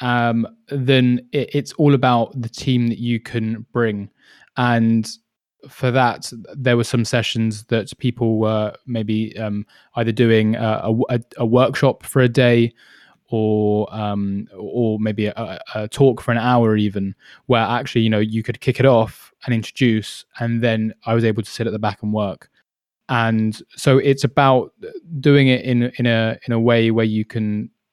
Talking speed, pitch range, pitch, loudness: 175 wpm, 110-125 Hz, 115 Hz, -19 LUFS